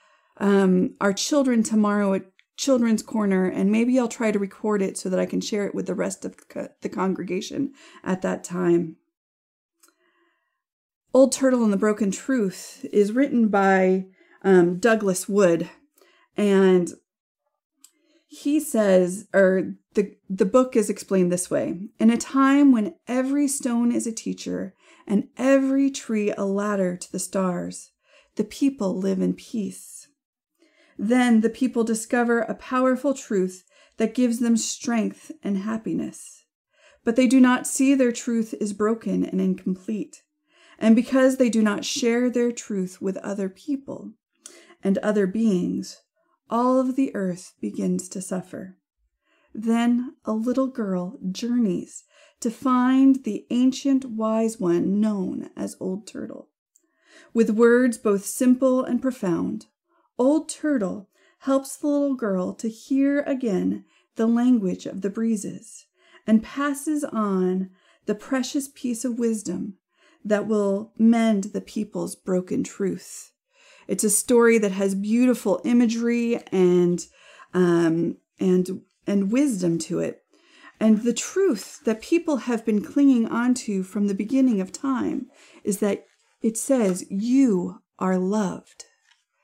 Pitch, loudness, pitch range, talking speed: 225 Hz, -23 LUFS, 195-270 Hz, 140 wpm